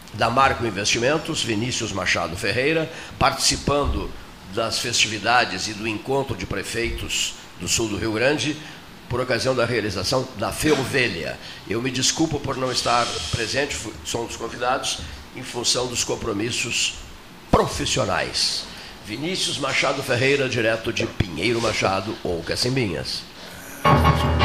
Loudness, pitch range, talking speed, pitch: -22 LUFS, 100-130 Hz, 125 wpm, 115 Hz